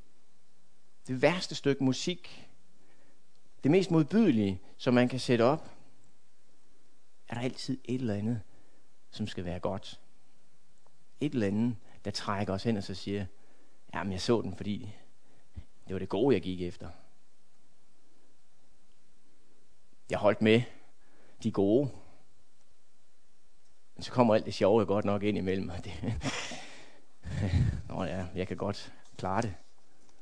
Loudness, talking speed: -31 LUFS, 135 wpm